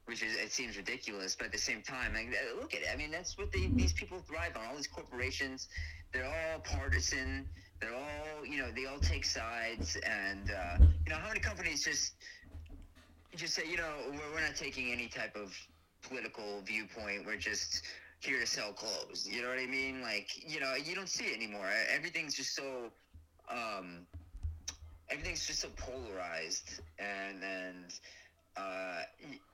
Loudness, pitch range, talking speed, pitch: -37 LUFS, 80-115 Hz, 185 wpm, 90 Hz